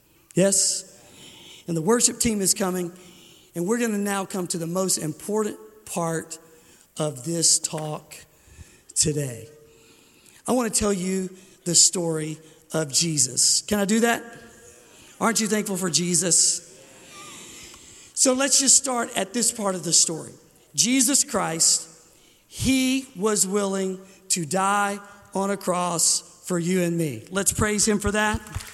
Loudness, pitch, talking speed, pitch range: -22 LUFS, 185 Hz, 145 wpm, 165-205 Hz